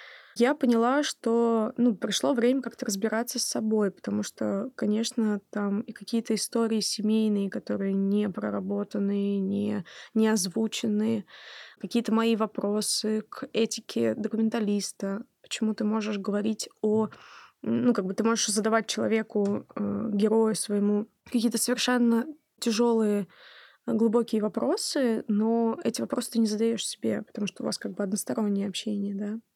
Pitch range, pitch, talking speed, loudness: 205-230 Hz, 220 Hz, 135 wpm, -27 LUFS